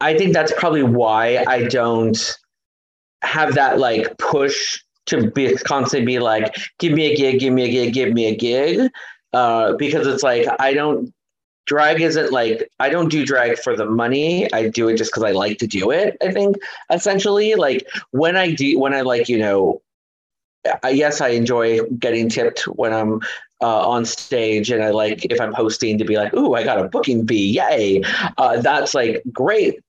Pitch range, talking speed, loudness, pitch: 110-155 Hz, 195 wpm, -18 LUFS, 120 Hz